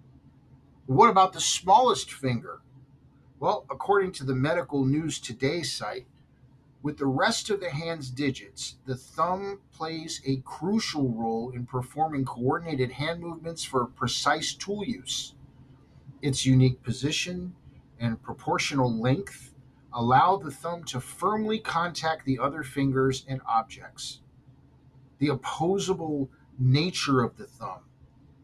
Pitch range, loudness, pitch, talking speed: 130-165 Hz, -27 LUFS, 140 Hz, 120 wpm